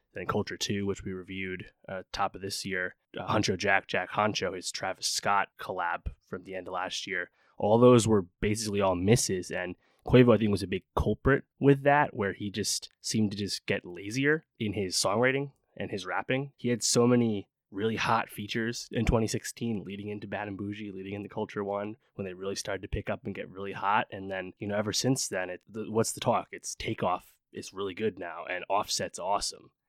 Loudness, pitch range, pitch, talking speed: -30 LUFS, 95-115 Hz, 105 Hz, 215 wpm